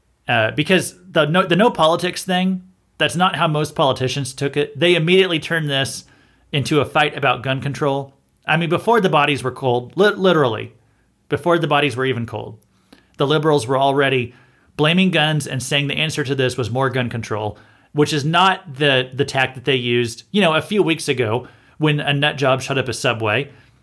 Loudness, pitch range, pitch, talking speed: -18 LUFS, 130-160 Hz, 145 Hz, 200 wpm